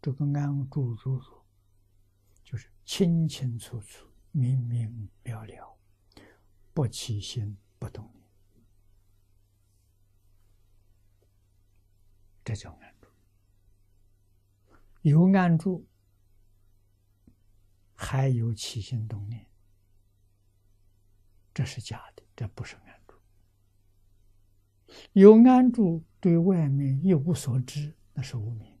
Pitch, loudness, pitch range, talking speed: 100 Hz, -25 LUFS, 100-125 Hz, 120 characters per minute